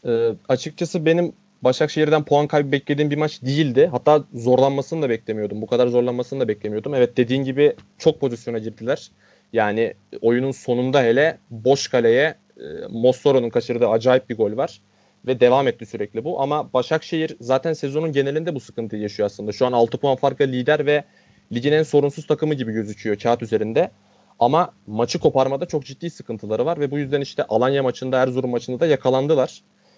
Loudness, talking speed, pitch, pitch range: -20 LUFS, 170 wpm, 130 Hz, 120-150 Hz